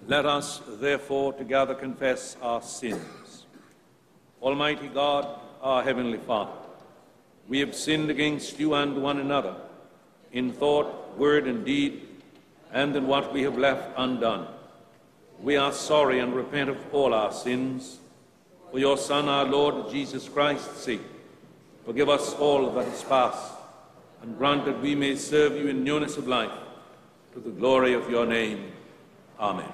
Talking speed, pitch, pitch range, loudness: 145 wpm, 140 Hz, 130-145 Hz, -26 LUFS